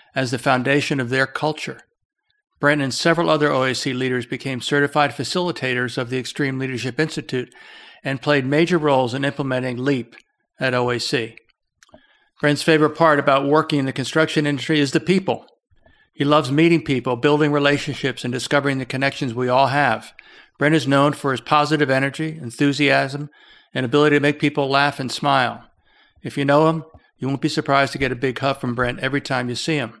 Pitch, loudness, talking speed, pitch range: 140 Hz, -20 LUFS, 180 wpm, 130-150 Hz